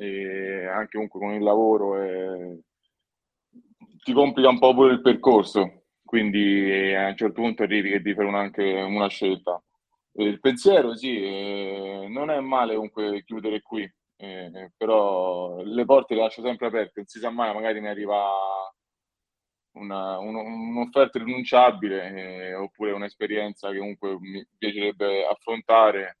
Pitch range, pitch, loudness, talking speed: 95-115 Hz, 105 Hz, -23 LUFS, 150 wpm